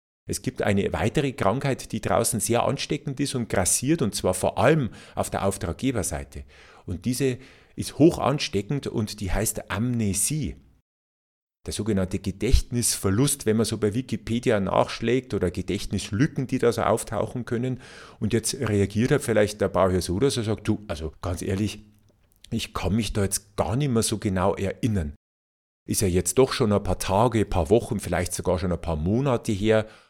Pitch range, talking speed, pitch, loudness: 95-120 Hz, 175 wpm, 105 Hz, -25 LUFS